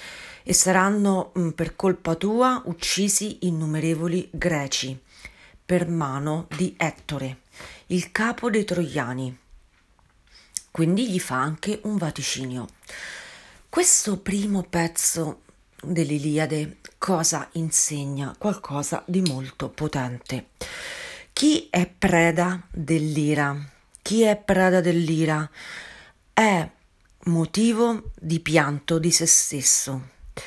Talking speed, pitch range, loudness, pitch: 95 wpm, 145-185 Hz, -23 LUFS, 165 Hz